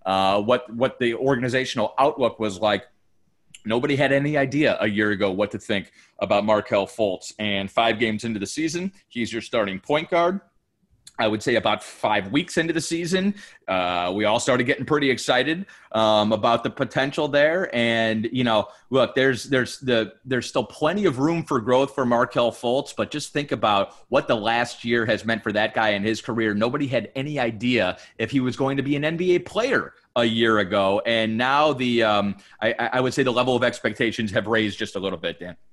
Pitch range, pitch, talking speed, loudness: 105-140 Hz, 120 Hz, 205 wpm, -22 LUFS